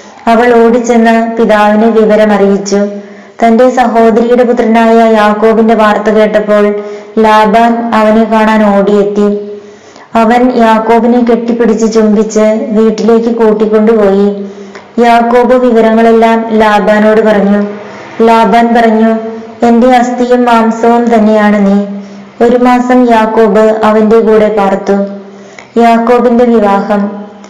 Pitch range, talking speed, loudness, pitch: 210-230 Hz, 85 wpm, -6 LUFS, 220 Hz